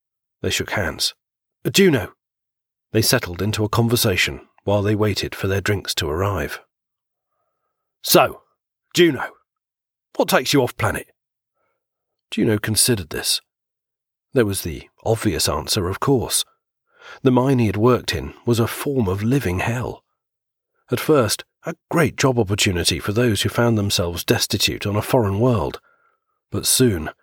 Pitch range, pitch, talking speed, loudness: 105-125 Hz, 115 Hz, 145 wpm, -20 LUFS